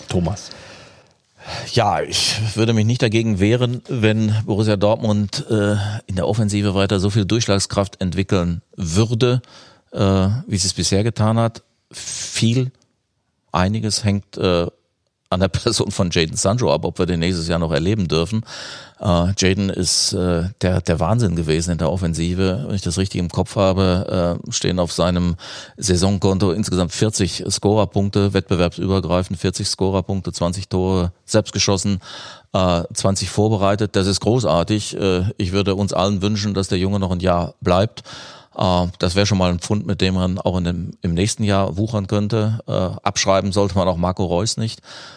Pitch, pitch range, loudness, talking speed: 100 Hz, 90-105 Hz, -19 LUFS, 165 wpm